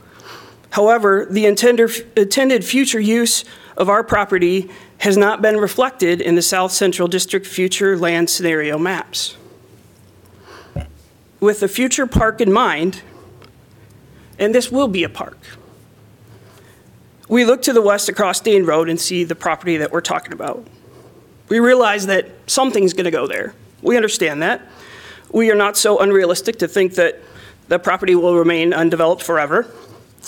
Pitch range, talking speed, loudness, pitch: 165-215 Hz, 145 wpm, -16 LUFS, 185 Hz